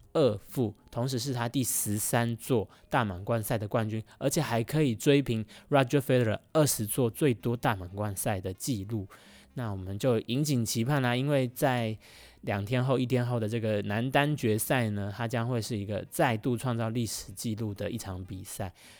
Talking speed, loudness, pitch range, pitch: 295 characters per minute, -30 LUFS, 105-130 Hz, 115 Hz